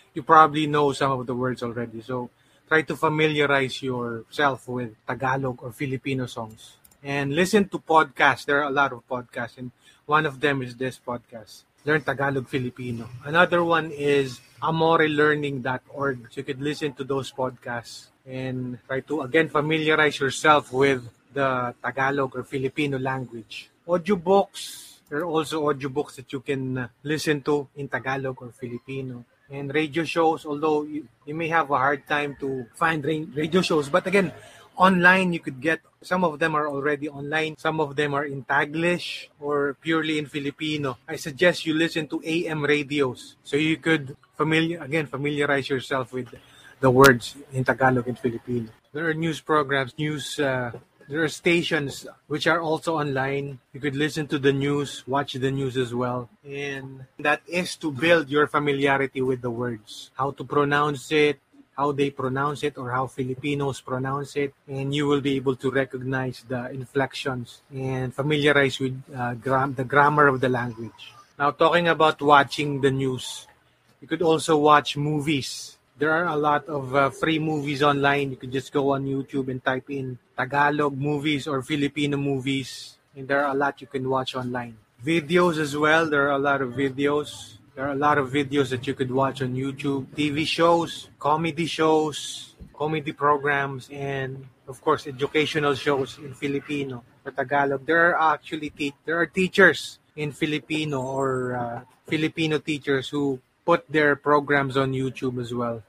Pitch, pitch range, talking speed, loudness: 140 Hz, 130-150 Hz, 170 wpm, -24 LUFS